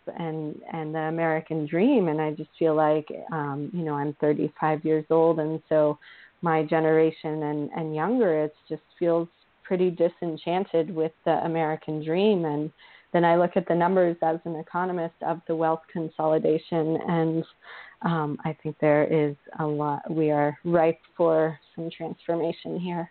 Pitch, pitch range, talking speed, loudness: 160 Hz, 155-170 Hz, 160 wpm, -26 LUFS